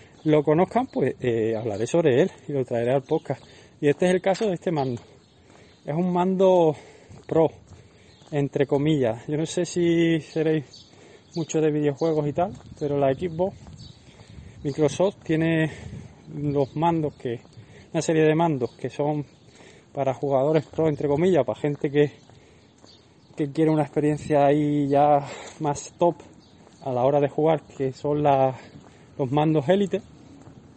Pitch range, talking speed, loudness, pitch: 135-160 Hz, 150 wpm, -24 LUFS, 145 Hz